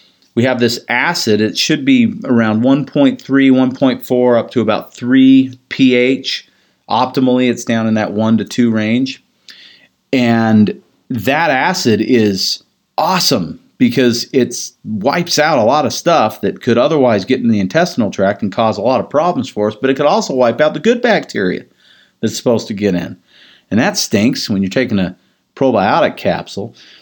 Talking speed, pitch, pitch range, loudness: 170 wpm, 125 Hz, 110-135 Hz, -13 LUFS